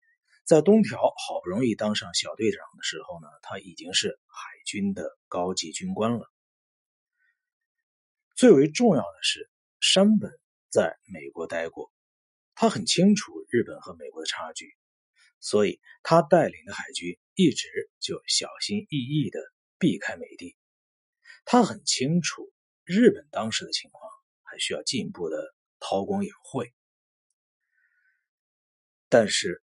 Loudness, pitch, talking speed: -25 LUFS, 215 Hz, 195 characters per minute